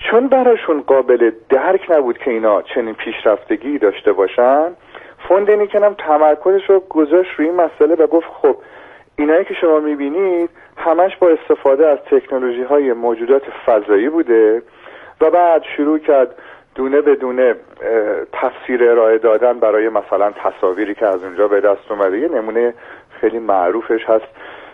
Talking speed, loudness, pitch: 145 wpm, -15 LUFS, 170 Hz